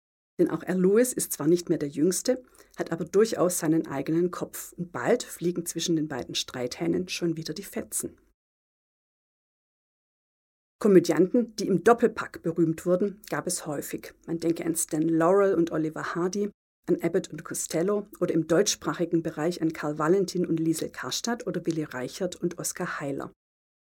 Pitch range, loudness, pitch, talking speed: 160-185 Hz, -27 LUFS, 170 Hz, 160 wpm